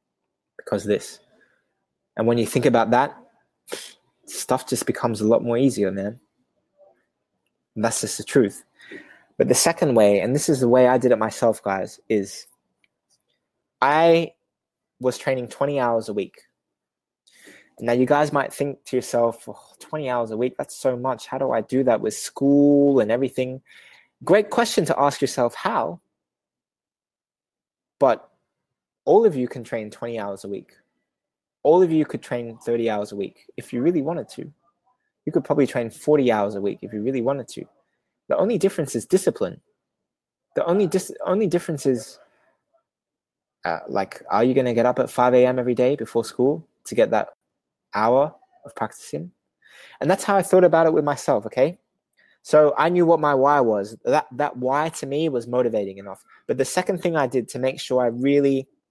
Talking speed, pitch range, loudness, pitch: 180 wpm, 120-155 Hz, -21 LUFS, 130 Hz